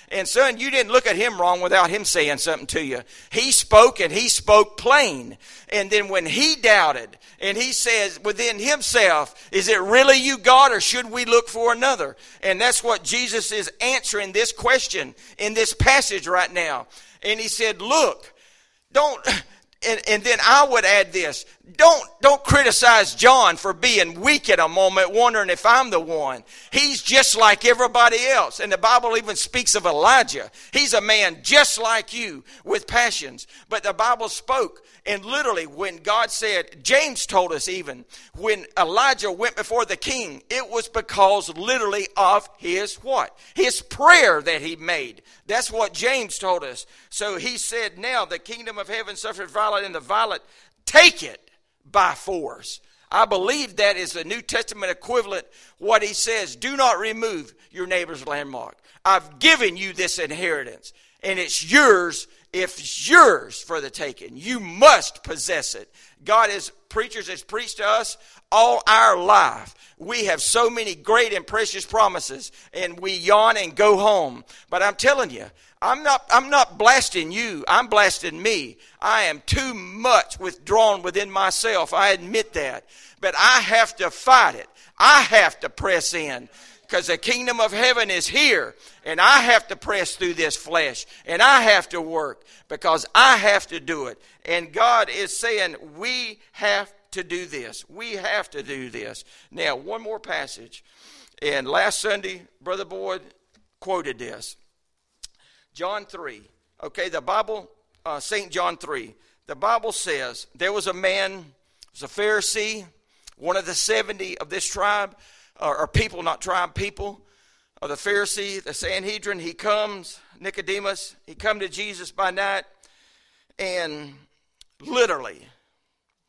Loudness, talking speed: -19 LUFS, 165 wpm